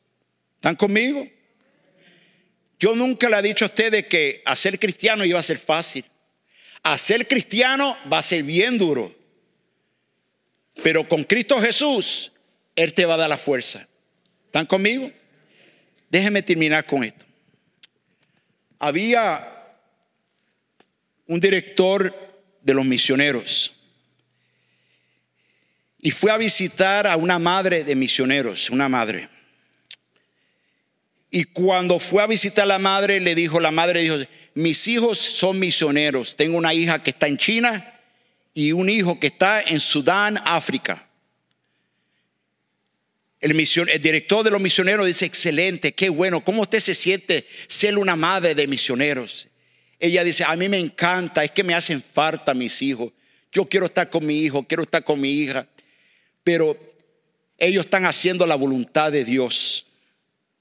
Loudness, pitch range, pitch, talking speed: -19 LUFS, 155-200 Hz, 175 Hz, 140 wpm